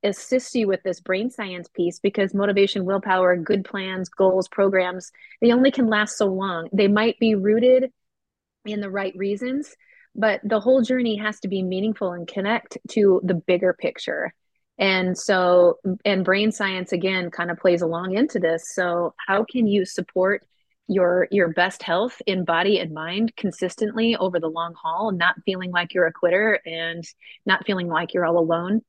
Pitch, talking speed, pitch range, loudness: 195 Hz, 175 wpm, 180-215 Hz, -22 LUFS